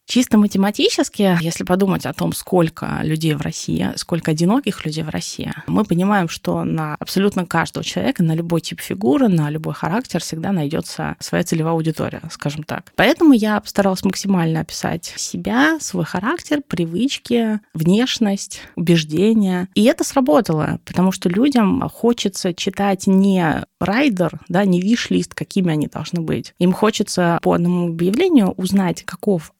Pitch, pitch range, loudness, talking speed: 185 Hz, 170-215 Hz, -18 LUFS, 145 wpm